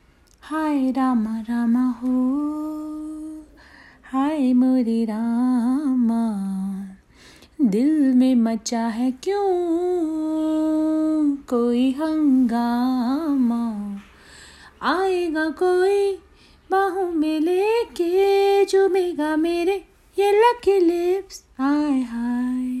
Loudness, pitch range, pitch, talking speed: -21 LUFS, 250-350 Hz, 295 Hz, 70 wpm